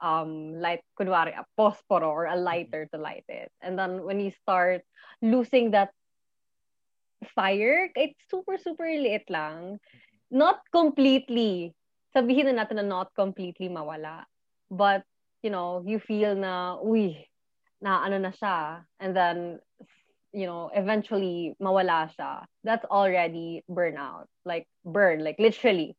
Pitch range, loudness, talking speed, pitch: 170-220 Hz, -27 LUFS, 125 wpm, 190 Hz